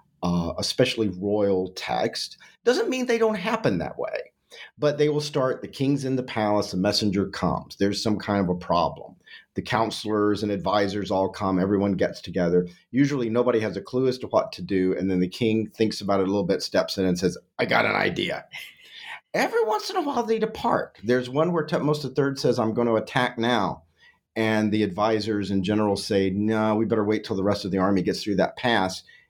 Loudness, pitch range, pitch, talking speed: -24 LUFS, 100-130 Hz, 110 Hz, 215 wpm